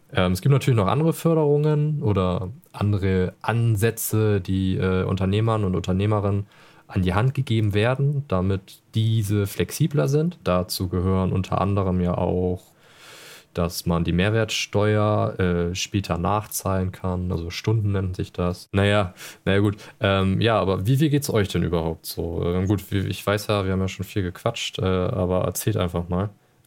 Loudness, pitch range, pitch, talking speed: -23 LUFS, 90-110 Hz, 100 Hz, 165 wpm